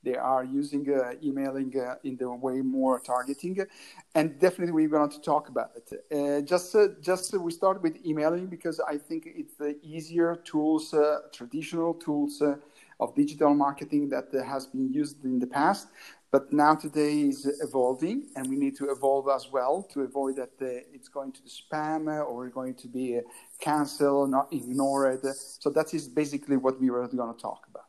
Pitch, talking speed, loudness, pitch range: 145 Hz, 190 wpm, -29 LUFS, 135-155 Hz